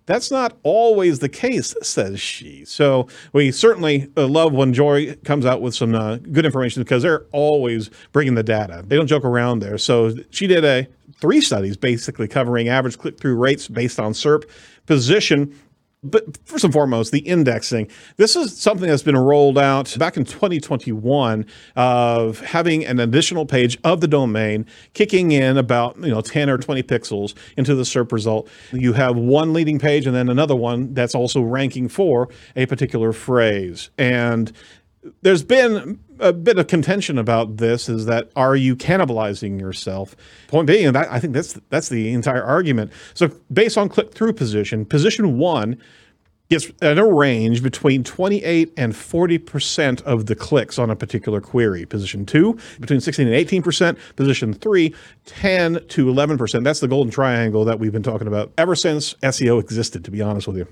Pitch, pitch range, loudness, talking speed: 135 Hz, 115-155 Hz, -18 LUFS, 175 wpm